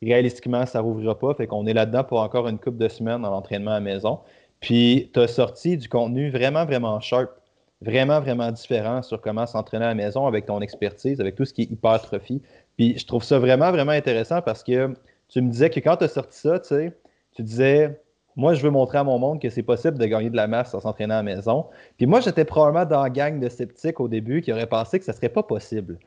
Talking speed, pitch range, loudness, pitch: 250 wpm, 110-140 Hz, -22 LUFS, 125 Hz